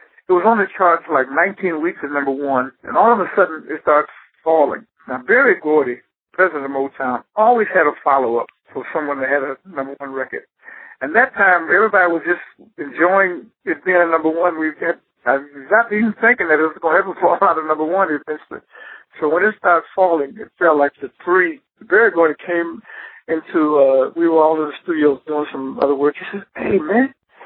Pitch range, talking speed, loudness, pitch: 145-195 Hz, 220 wpm, -17 LUFS, 165 Hz